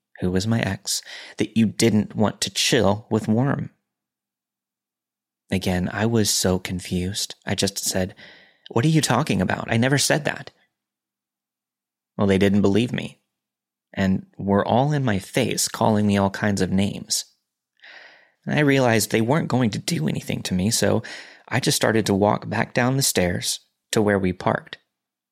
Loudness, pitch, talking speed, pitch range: -22 LUFS, 100 Hz, 170 wpm, 90-110 Hz